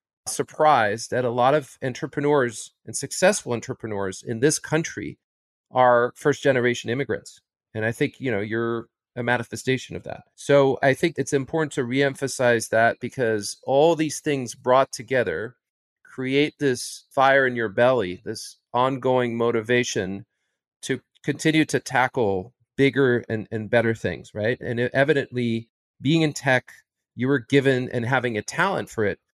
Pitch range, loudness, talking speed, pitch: 115-140 Hz, -23 LUFS, 150 wpm, 125 Hz